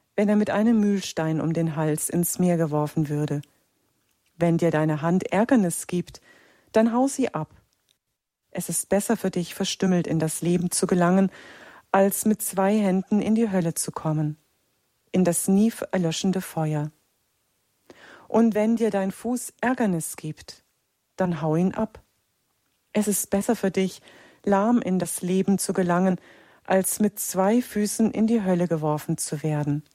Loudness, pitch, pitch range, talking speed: -24 LUFS, 185 Hz, 165-210 Hz, 160 wpm